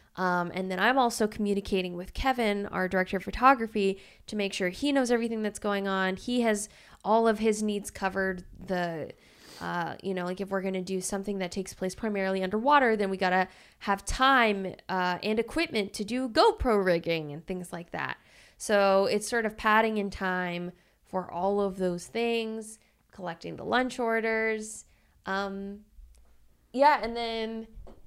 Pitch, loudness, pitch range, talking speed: 200 Hz, -28 LUFS, 185-225 Hz, 170 wpm